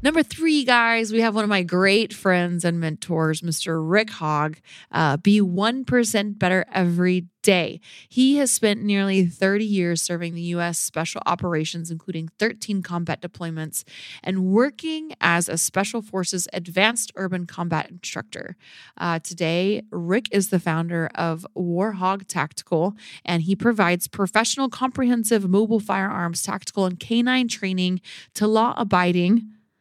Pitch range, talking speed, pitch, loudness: 170-215 Hz, 140 wpm, 190 Hz, -22 LUFS